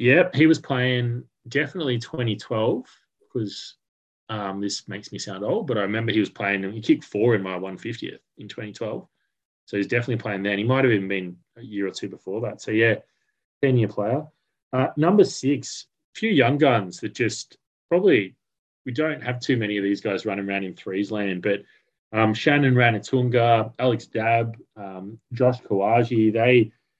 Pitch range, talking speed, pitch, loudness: 100-130 Hz, 180 wpm, 115 Hz, -23 LUFS